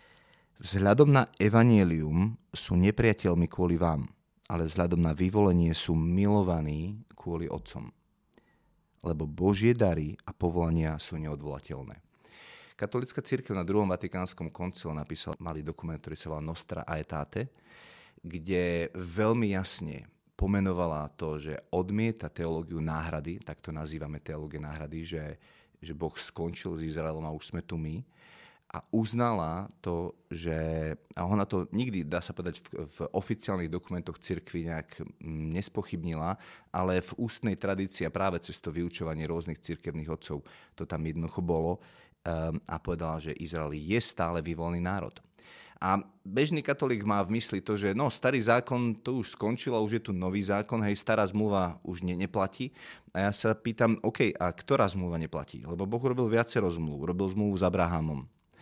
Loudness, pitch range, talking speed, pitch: -31 LUFS, 80-100 Hz, 150 wpm, 90 Hz